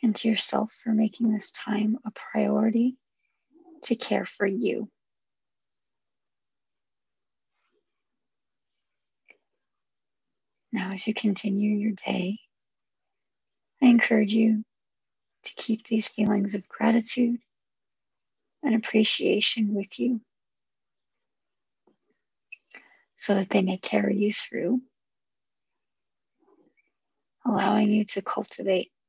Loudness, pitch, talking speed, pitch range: -25 LUFS, 220 Hz, 90 wpm, 210-245 Hz